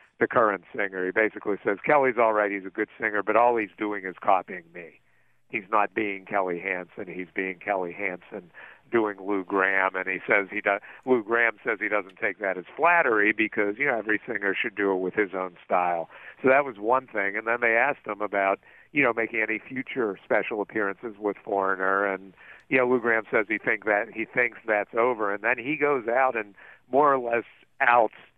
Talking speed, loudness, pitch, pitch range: 215 wpm, -25 LUFS, 105 Hz, 100-115 Hz